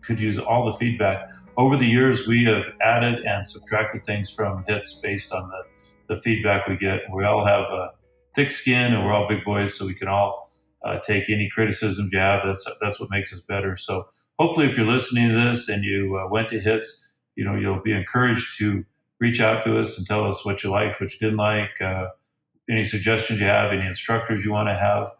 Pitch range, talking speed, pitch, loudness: 100-115 Hz, 225 wpm, 105 Hz, -22 LUFS